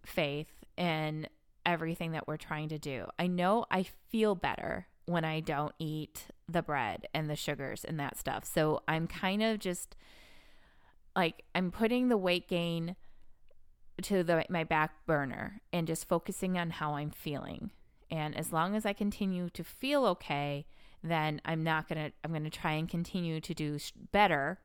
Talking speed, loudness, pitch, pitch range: 175 wpm, -34 LUFS, 165 Hz, 155-180 Hz